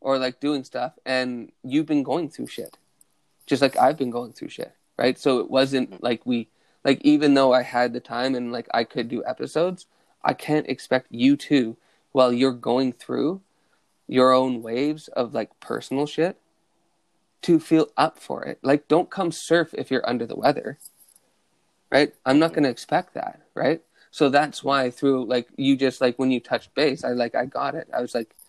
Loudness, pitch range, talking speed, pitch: -23 LUFS, 125-150 Hz, 195 wpm, 135 Hz